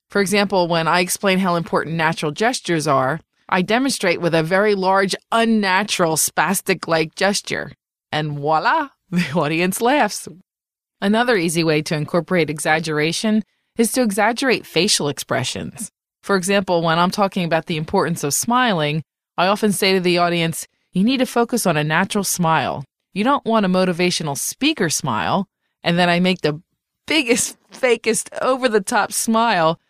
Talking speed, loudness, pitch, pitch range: 155 wpm, -18 LUFS, 185 Hz, 165-215 Hz